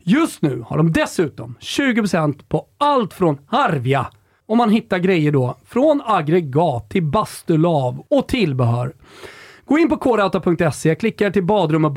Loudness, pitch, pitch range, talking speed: -18 LUFS, 180 Hz, 150-235 Hz, 150 wpm